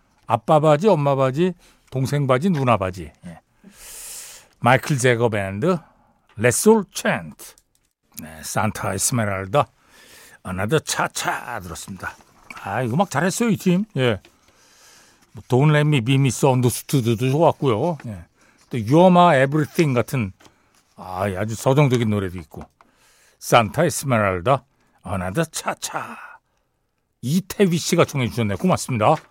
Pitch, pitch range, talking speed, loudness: 130 Hz, 110-160 Hz, 260 characters per minute, -20 LUFS